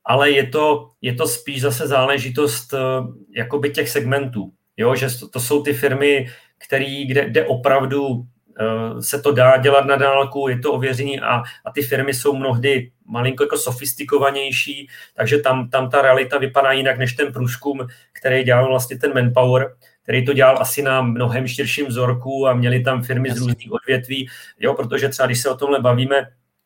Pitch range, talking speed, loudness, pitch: 125-140 Hz, 180 wpm, -18 LUFS, 135 Hz